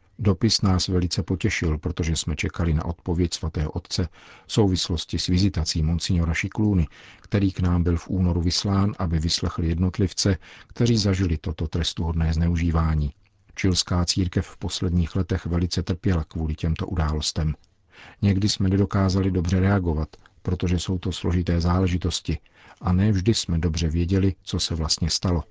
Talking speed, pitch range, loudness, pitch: 145 wpm, 85-95 Hz, -24 LUFS, 90 Hz